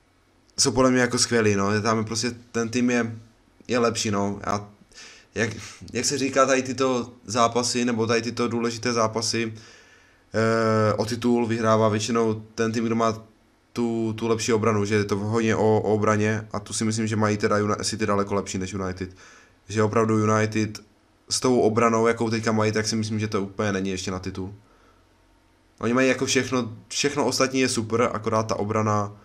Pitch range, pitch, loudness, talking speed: 105-120 Hz, 110 Hz, -23 LUFS, 185 wpm